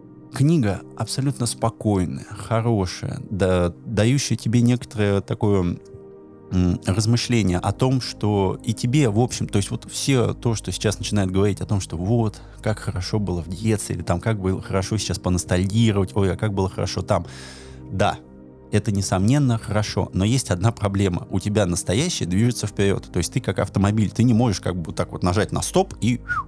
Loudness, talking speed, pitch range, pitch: -22 LUFS, 175 wpm, 95-115 Hz, 105 Hz